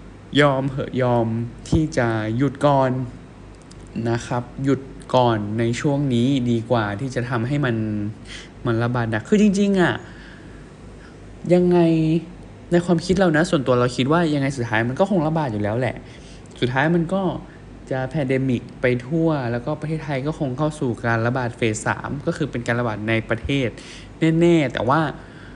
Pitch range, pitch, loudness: 115-155 Hz, 130 Hz, -21 LUFS